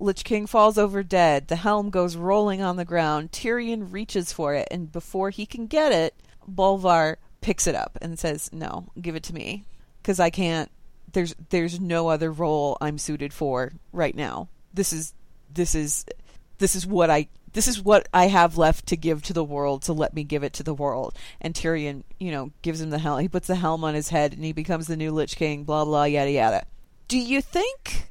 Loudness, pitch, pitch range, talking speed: -24 LUFS, 165 Hz, 150-190 Hz, 220 wpm